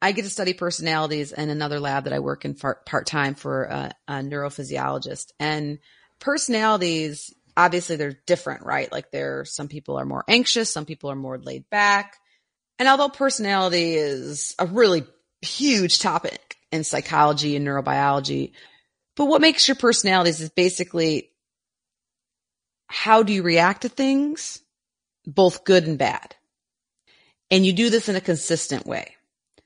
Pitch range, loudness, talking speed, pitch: 145-205 Hz, -22 LUFS, 150 wpm, 170 Hz